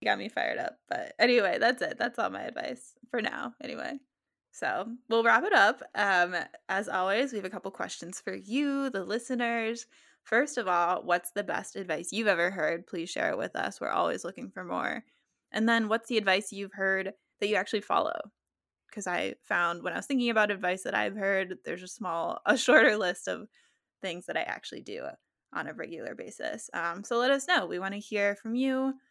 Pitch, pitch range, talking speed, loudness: 210 Hz, 185-245 Hz, 210 wpm, -30 LUFS